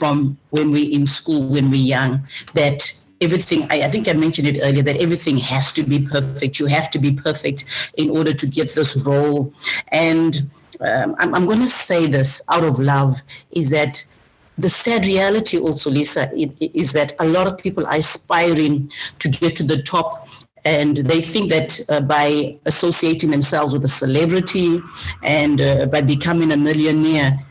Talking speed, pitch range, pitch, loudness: 180 wpm, 140-165 Hz, 150 Hz, -18 LUFS